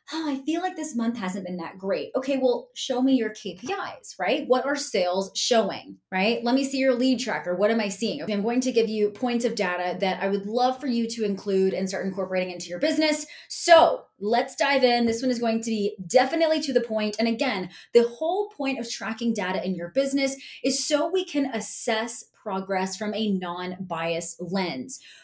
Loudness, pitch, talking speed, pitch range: -25 LUFS, 230 Hz, 215 wpm, 195-265 Hz